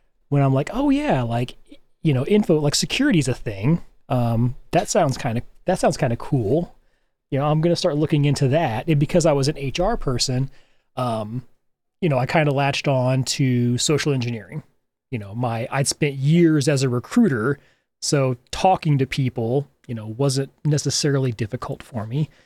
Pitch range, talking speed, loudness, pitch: 125-155 Hz, 185 wpm, -21 LUFS, 140 Hz